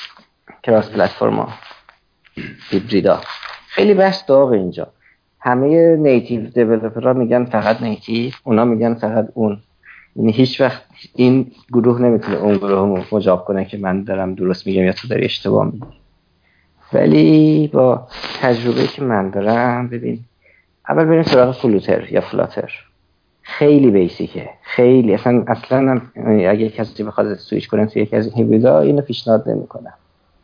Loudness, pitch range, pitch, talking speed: -15 LUFS, 105-125 Hz, 115 Hz, 135 wpm